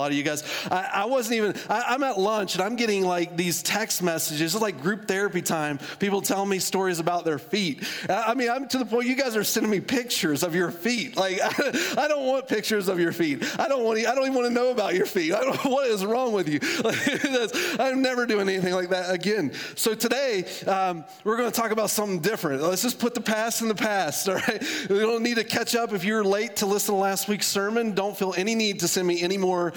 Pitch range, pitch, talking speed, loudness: 185-230 Hz, 205 Hz, 260 wpm, -25 LUFS